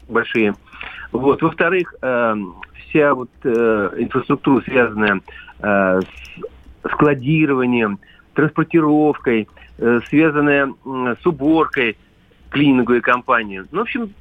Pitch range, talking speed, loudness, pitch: 105-150 Hz, 95 wpm, -17 LUFS, 125 Hz